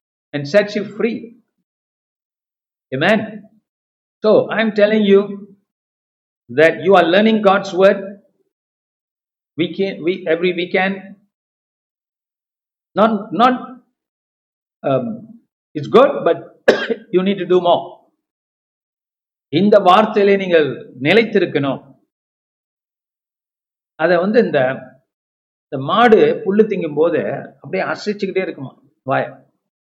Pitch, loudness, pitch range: 200 Hz, -15 LUFS, 175-220 Hz